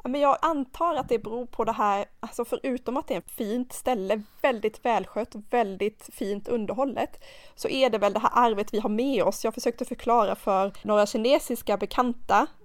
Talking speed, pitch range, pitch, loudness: 200 wpm, 210-255 Hz, 235 Hz, -26 LUFS